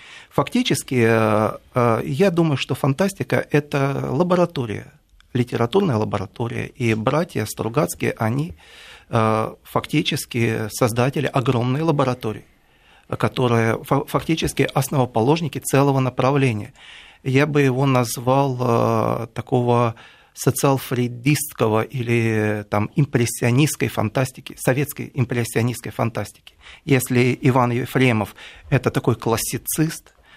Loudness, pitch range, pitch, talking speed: -20 LUFS, 115-140 Hz, 130 Hz, 80 wpm